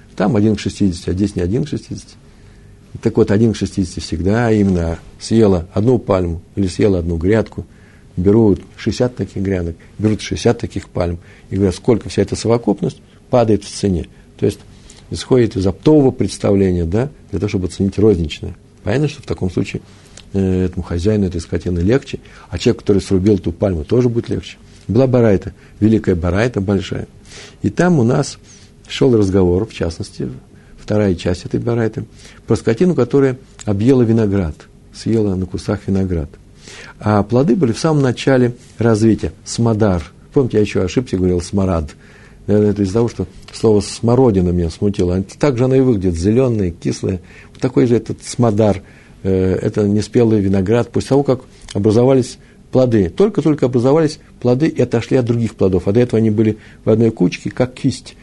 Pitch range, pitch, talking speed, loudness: 95-115 Hz, 105 Hz, 165 wpm, -16 LUFS